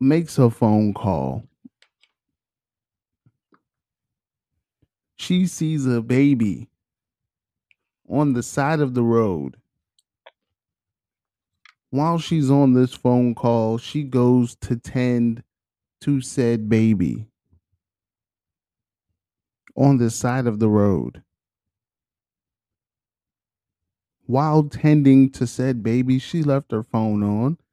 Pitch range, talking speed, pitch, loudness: 100-130 Hz, 95 wpm, 115 Hz, -20 LUFS